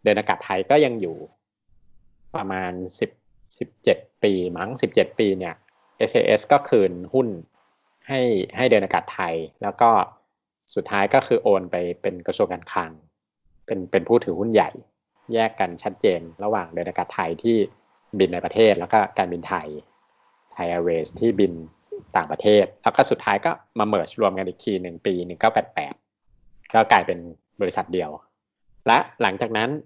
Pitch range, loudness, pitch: 90-115 Hz, -22 LUFS, 95 Hz